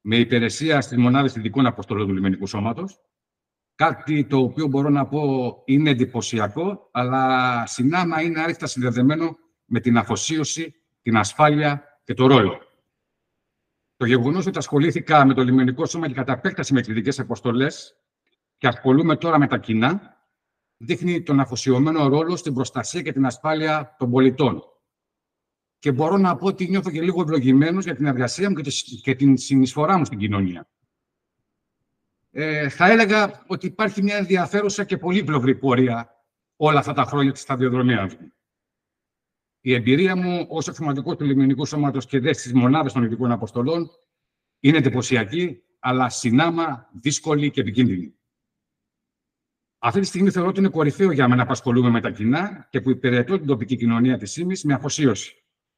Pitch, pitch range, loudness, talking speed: 140 Hz, 125-160 Hz, -21 LUFS, 155 wpm